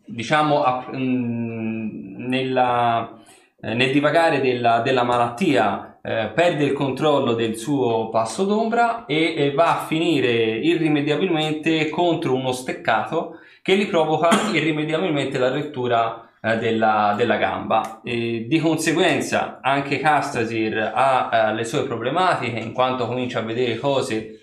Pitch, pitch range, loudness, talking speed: 130 Hz, 115-155 Hz, -21 LUFS, 130 wpm